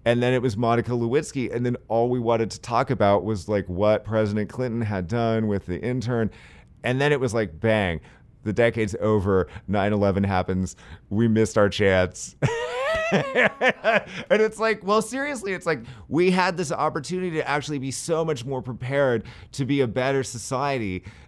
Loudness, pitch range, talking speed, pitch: -24 LUFS, 105-140 Hz, 175 wpm, 120 Hz